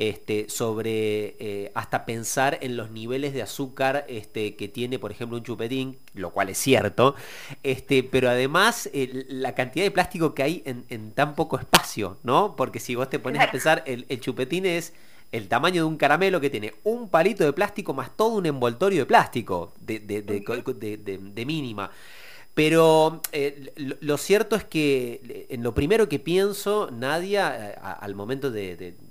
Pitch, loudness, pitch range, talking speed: 130 Hz, -24 LUFS, 115-155 Hz, 190 wpm